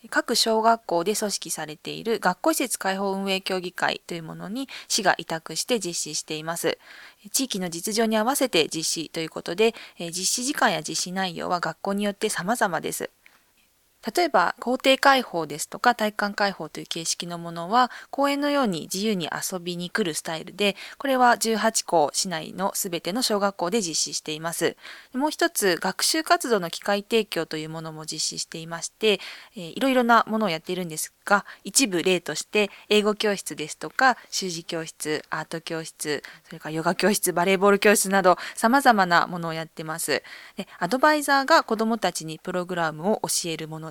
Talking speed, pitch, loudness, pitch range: 370 characters per minute, 195 Hz, -24 LUFS, 165-225 Hz